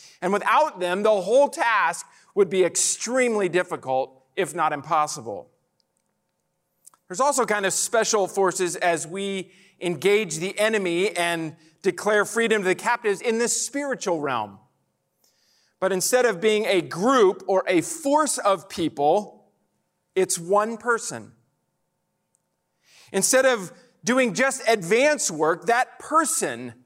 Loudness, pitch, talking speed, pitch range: -22 LUFS, 190 Hz, 125 wpm, 175-230 Hz